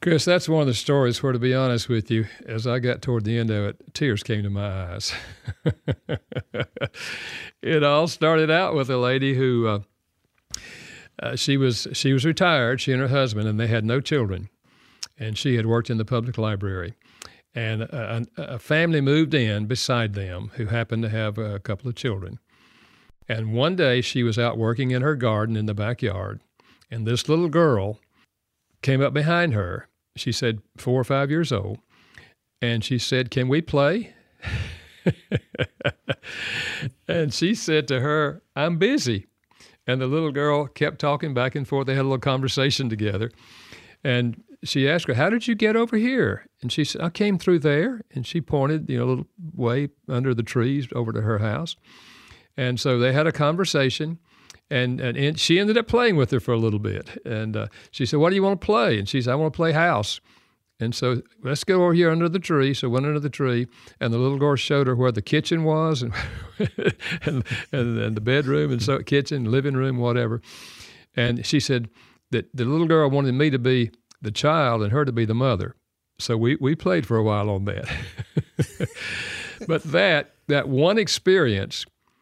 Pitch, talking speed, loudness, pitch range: 130 Hz, 195 wpm, -23 LUFS, 115-150 Hz